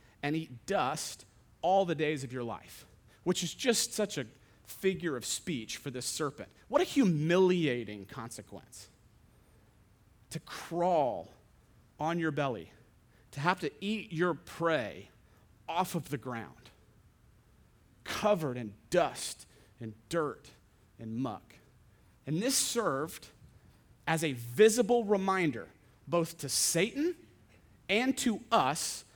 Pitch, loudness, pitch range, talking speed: 140 Hz, -32 LUFS, 115-175 Hz, 120 wpm